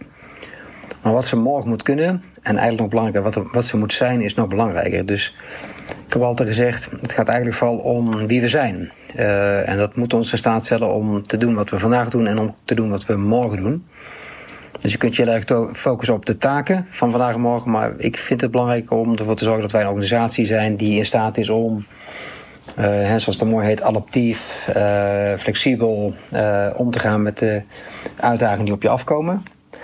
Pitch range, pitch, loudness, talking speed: 105-120 Hz, 115 Hz, -19 LUFS, 220 wpm